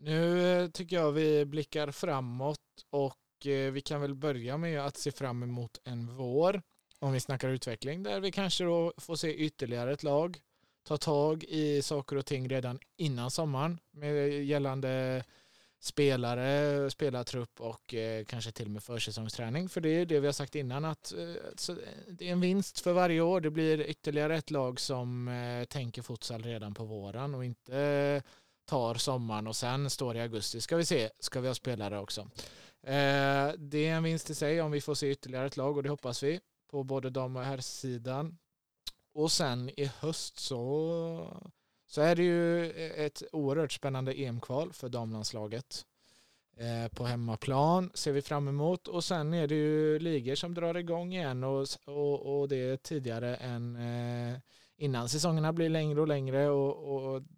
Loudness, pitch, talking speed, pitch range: -33 LUFS, 140 Hz, 170 wpm, 125-155 Hz